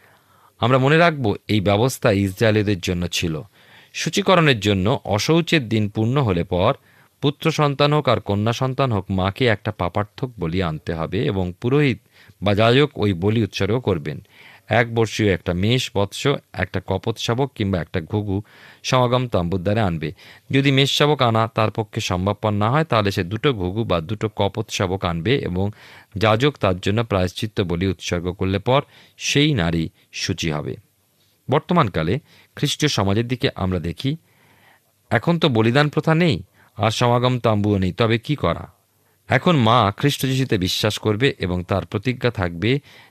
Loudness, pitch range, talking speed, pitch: -20 LUFS, 95-130 Hz, 140 wpm, 110 Hz